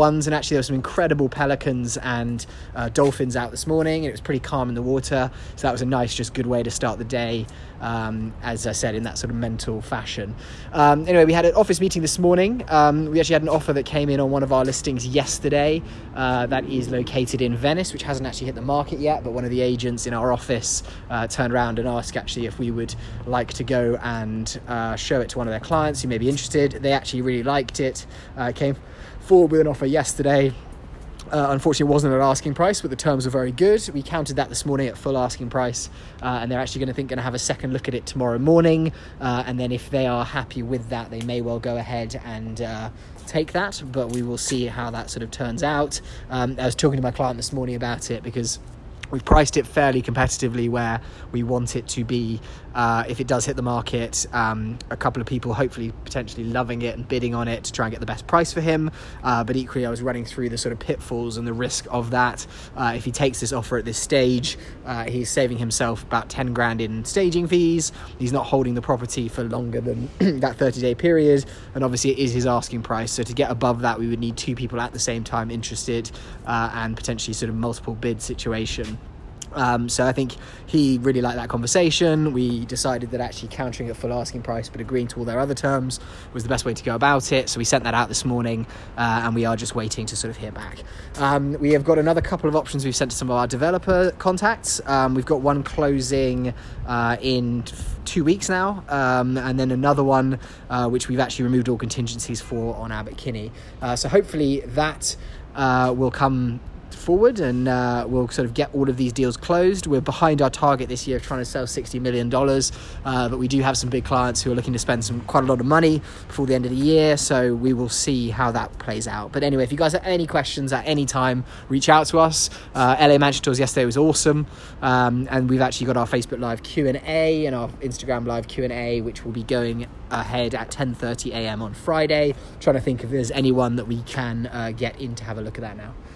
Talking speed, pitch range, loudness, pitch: 240 wpm, 120-140 Hz, -22 LUFS, 125 Hz